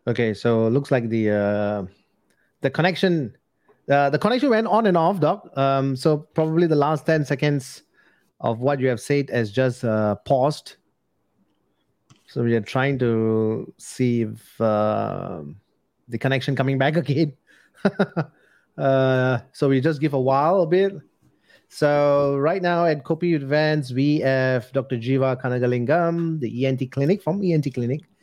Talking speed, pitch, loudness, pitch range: 155 wpm, 135 Hz, -22 LUFS, 120-155 Hz